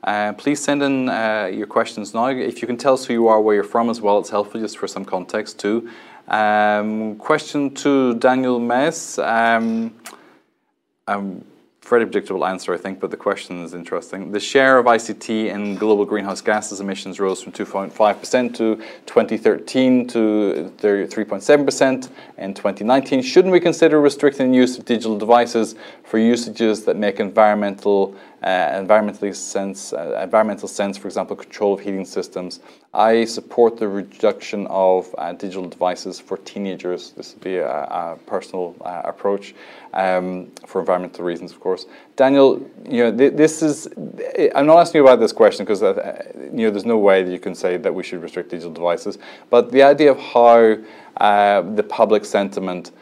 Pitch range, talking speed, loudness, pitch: 100-130 Hz, 175 wpm, -18 LUFS, 110 Hz